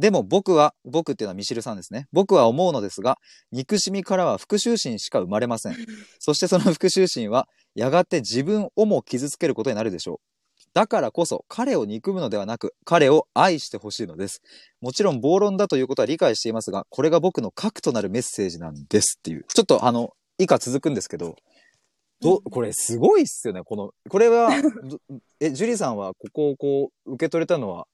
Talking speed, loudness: 410 characters per minute, -22 LUFS